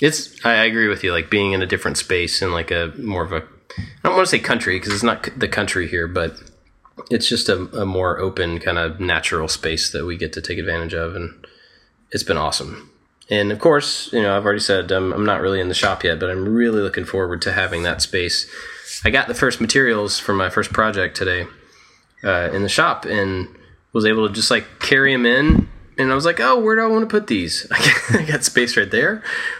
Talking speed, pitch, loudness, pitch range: 235 wpm, 105 Hz, -18 LUFS, 95-130 Hz